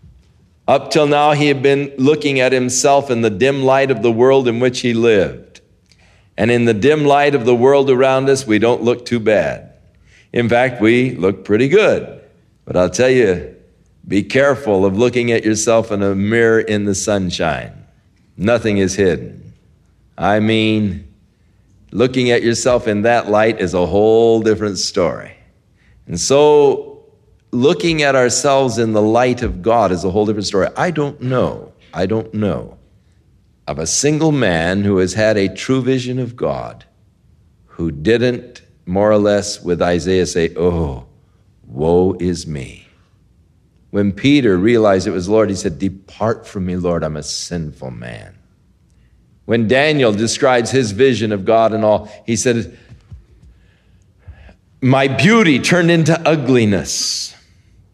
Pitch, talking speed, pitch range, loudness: 110 Hz, 155 wpm, 95-125 Hz, -15 LUFS